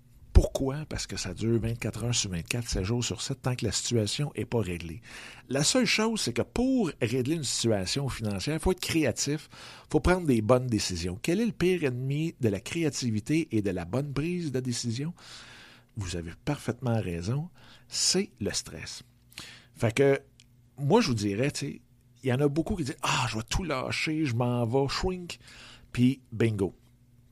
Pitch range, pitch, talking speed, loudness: 115-145 Hz, 125 Hz, 185 wpm, -29 LUFS